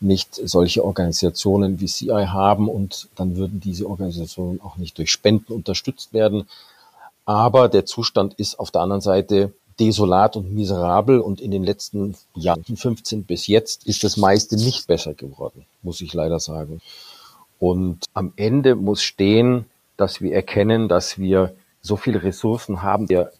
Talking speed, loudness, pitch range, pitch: 155 wpm, -20 LUFS, 90-105 Hz, 100 Hz